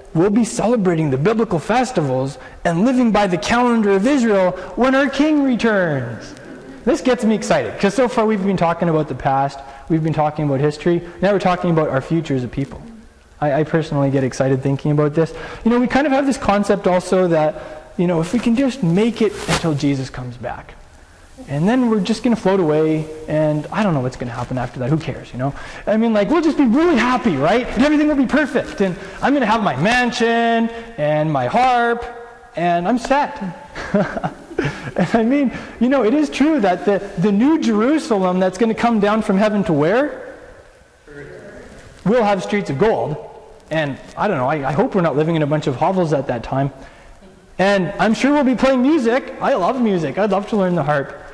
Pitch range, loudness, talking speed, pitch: 155-235 Hz, -17 LUFS, 210 wpm, 195 Hz